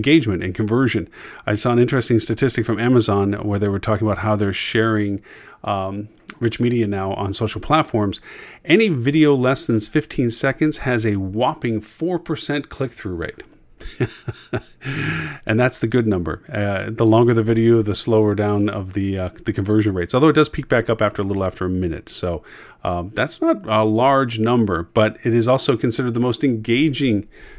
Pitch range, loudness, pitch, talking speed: 105-125 Hz, -19 LUFS, 110 Hz, 185 wpm